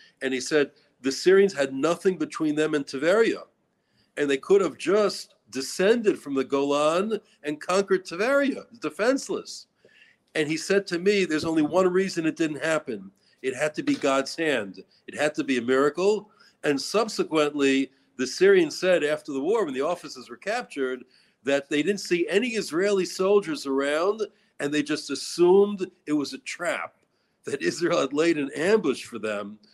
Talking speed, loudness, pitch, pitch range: 170 wpm, -25 LUFS, 160 Hz, 140-200 Hz